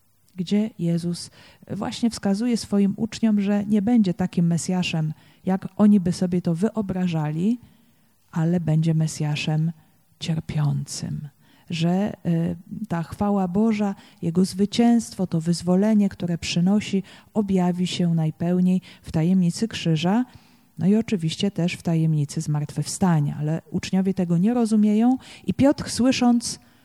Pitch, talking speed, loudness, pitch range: 180 Hz, 120 wpm, -23 LUFS, 165-205 Hz